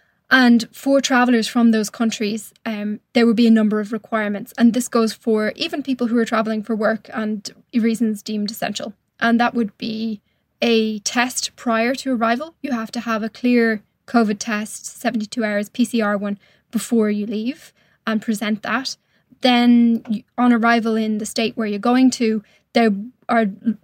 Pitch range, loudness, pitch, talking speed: 215-240 Hz, -19 LUFS, 225 Hz, 170 wpm